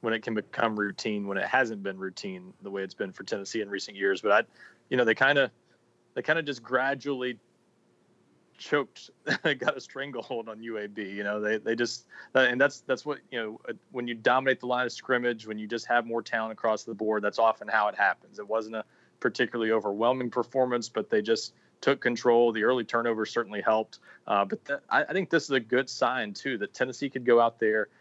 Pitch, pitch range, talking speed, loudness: 115 Hz, 110-125 Hz, 225 wpm, -28 LUFS